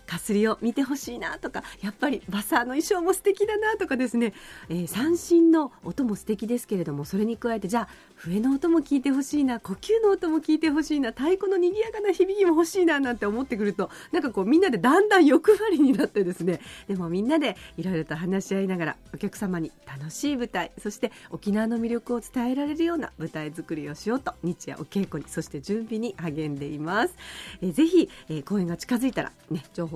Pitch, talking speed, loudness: 235 Hz, 430 characters per minute, -25 LUFS